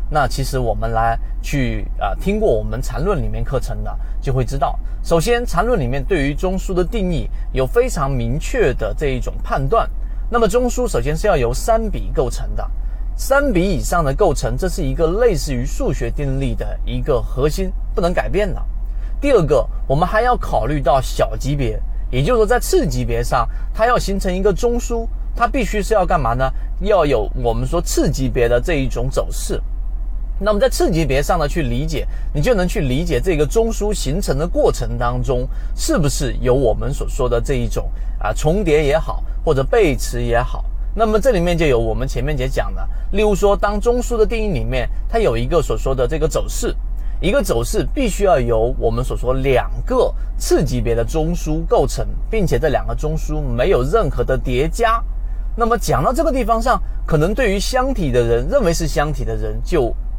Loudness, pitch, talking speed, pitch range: -19 LUFS, 145 Hz, 290 characters per minute, 120-195 Hz